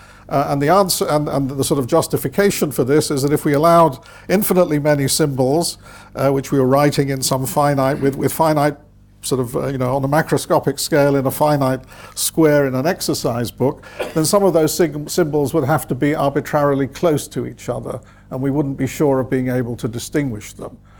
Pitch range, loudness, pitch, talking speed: 130-155 Hz, -17 LUFS, 140 Hz, 210 wpm